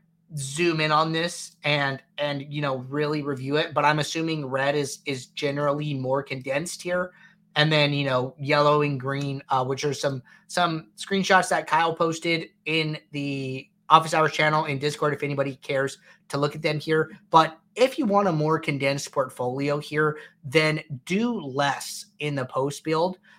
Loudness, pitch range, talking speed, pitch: -25 LUFS, 140-165 Hz, 175 wpm, 150 Hz